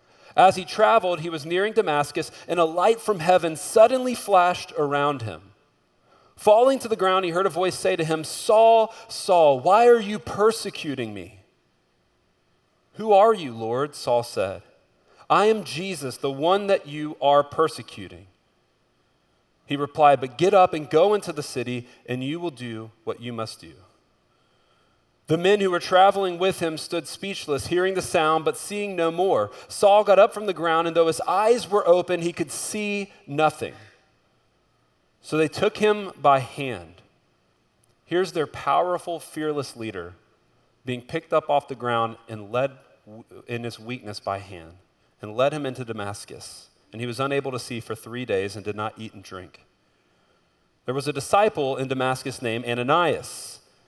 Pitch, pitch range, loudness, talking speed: 150 Hz, 120-185 Hz, -22 LUFS, 170 wpm